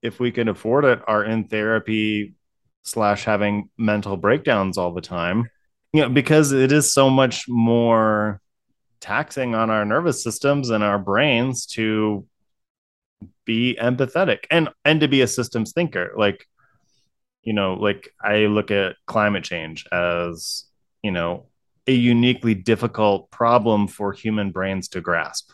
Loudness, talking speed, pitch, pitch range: -20 LUFS, 145 wpm, 110 Hz, 105-125 Hz